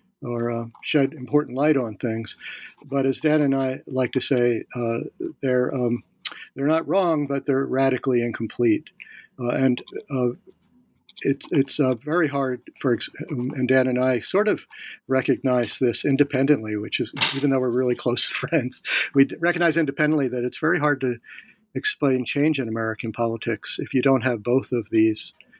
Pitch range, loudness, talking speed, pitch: 120-145 Hz, -23 LUFS, 165 wpm, 130 Hz